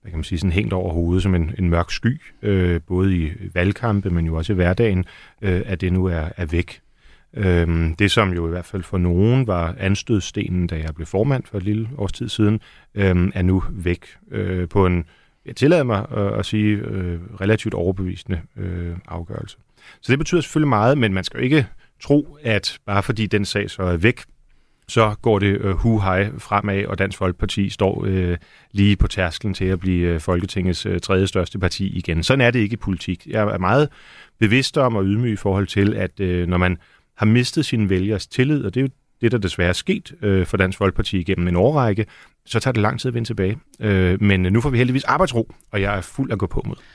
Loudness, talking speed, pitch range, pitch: -20 LUFS, 220 wpm, 90-110 Hz, 100 Hz